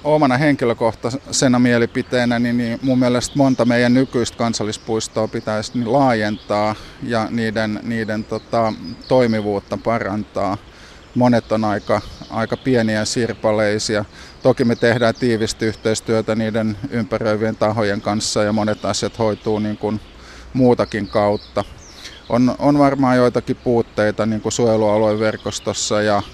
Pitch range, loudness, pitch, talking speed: 105-120 Hz, -18 LUFS, 110 Hz, 110 wpm